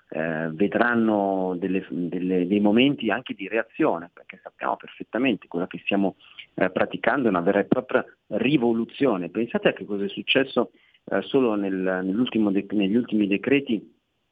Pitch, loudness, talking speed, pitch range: 100 Hz, -24 LUFS, 155 wpm, 95-115 Hz